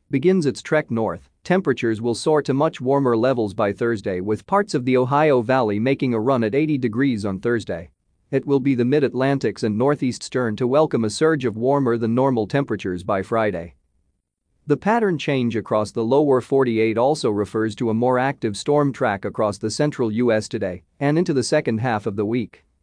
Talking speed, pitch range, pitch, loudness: 195 wpm, 110-140 Hz, 120 Hz, -21 LUFS